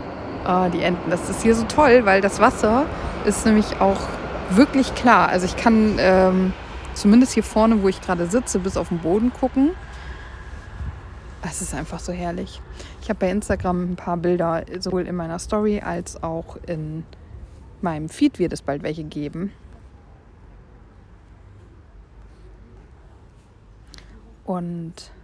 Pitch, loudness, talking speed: 175 Hz, -20 LUFS, 140 wpm